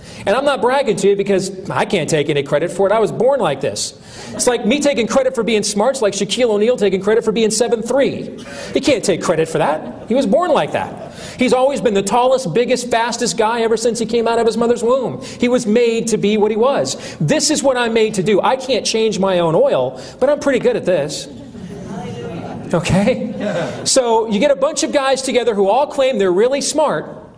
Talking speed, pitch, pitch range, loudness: 230 wpm, 230 Hz, 205-255 Hz, -16 LUFS